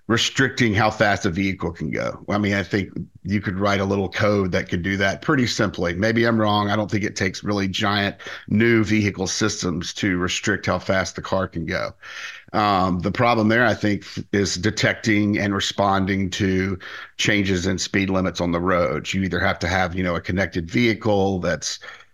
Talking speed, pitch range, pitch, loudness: 200 wpm, 95-105 Hz, 100 Hz, -21 LUFS